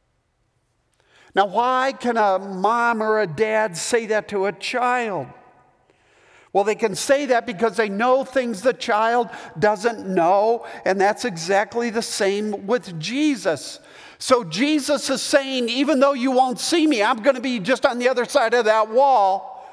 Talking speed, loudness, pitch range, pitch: 165 wpm, -20 LUFS, 200-255 Hz, 235 Hz